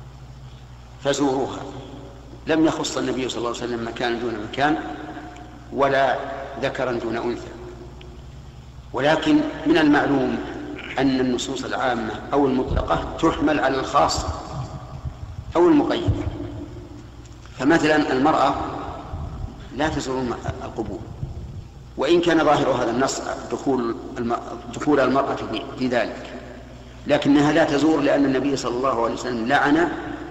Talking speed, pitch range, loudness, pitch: 105 wpm, 120-150 Hz, -22 LUFS, 135 Hz